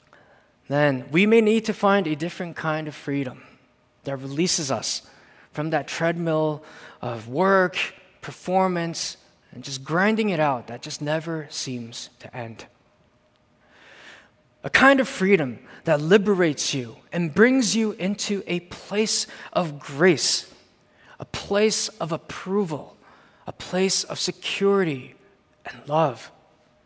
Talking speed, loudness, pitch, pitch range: 125 wpm, -23 LUFS, 165 Hz, 145-195 Hz